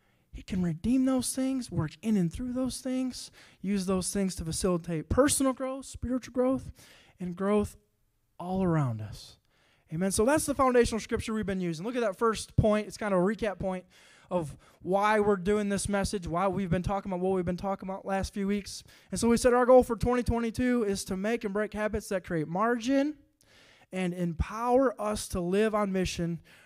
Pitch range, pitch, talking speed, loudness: 185-240 Hz, 200 Hz, 200 wpm, -29 LUFS